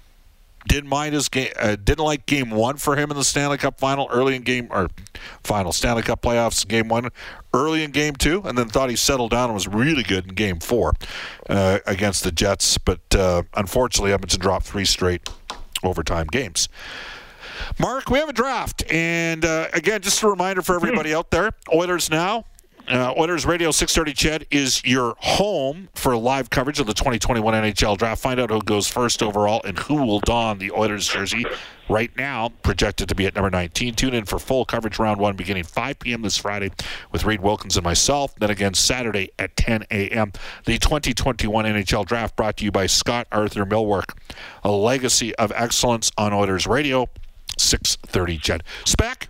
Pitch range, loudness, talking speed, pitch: 100-135 Hz, -21 LUFS, 190 wpm, 115 Hz